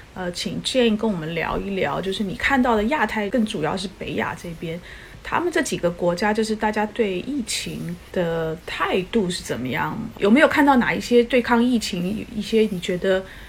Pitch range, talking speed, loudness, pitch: 185-235 Hz, 290 characters per minute, -22 LUFS, 210 Hz